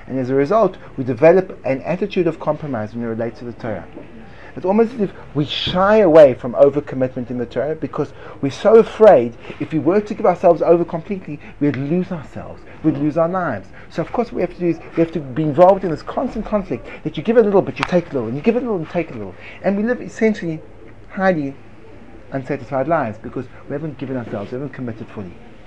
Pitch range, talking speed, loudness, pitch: 125-180 Hz, 240 wpm, -18 LUFS, 145 Hz